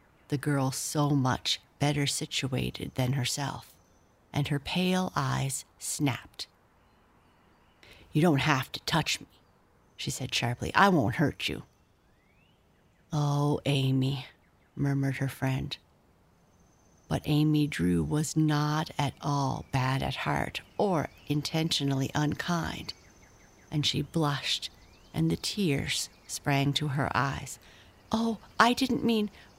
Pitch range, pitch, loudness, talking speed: 105-150 Hz, 135 Hz, -29 LUFS, 120 wpm